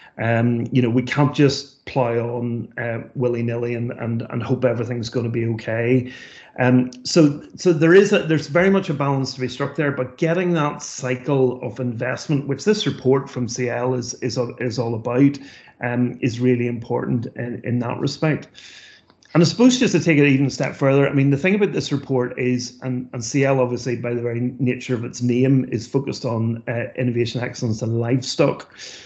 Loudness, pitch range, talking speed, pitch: -20 LUFS, 120-140 Hz, 200 wpm, 125 Hz